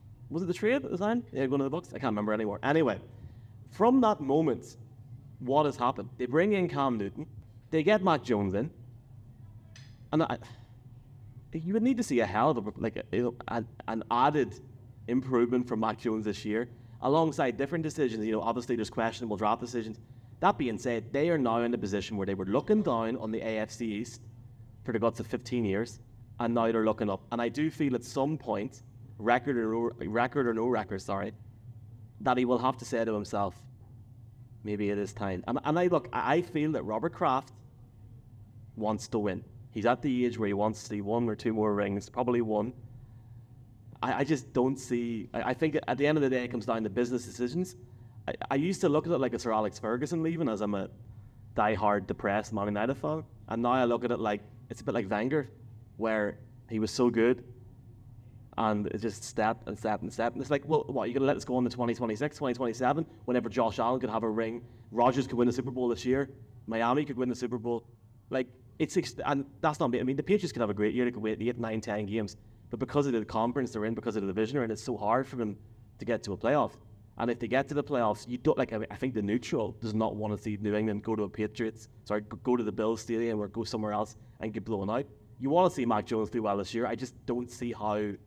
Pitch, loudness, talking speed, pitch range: 120 Hz, -31 LUFS, 235 wpm, 110-125 Hz